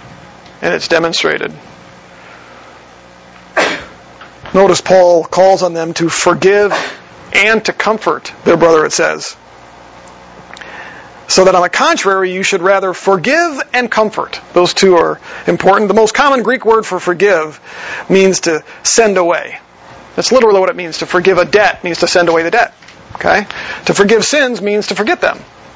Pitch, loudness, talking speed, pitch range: 180 Hz, -11 LUFS, 155 wpm, 155-205 Hz